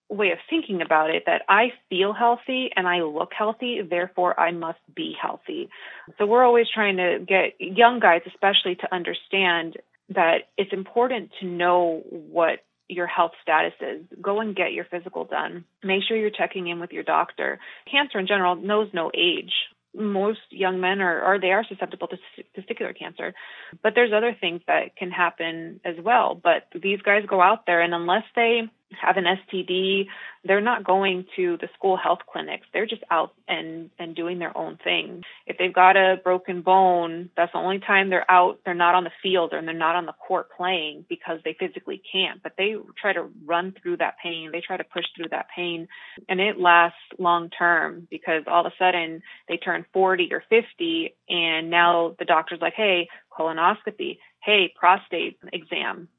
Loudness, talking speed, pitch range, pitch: -23 LUFS, 190 wpm, 175-210 Hz, 185 Hz